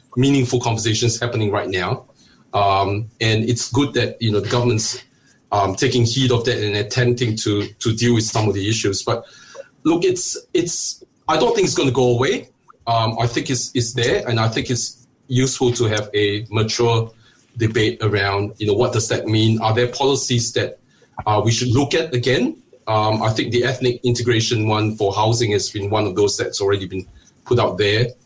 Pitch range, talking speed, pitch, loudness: 110-125 Hz, 200 wpm, 120 Hz, -19 LUFS